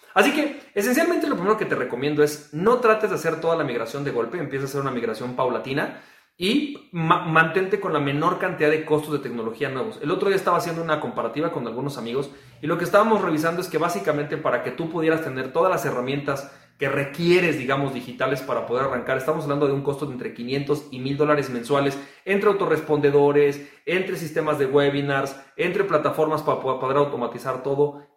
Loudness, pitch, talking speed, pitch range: -23 LUFS, 150 Hz, 200 wpm, 140-170 Hz